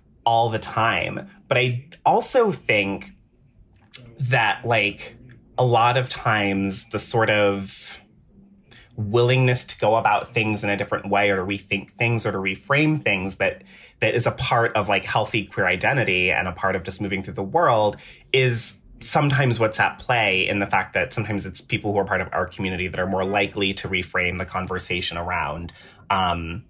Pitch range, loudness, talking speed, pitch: 95-120 Hz, -22 LUFS, 180 wpm, 105 Hz